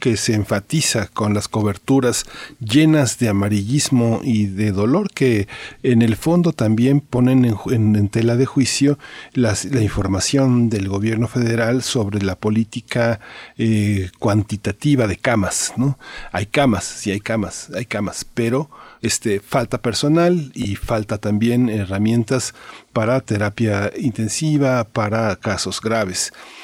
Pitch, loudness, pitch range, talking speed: 115 Hz, -19 LUFS, 105-130 Hz, 135 wpm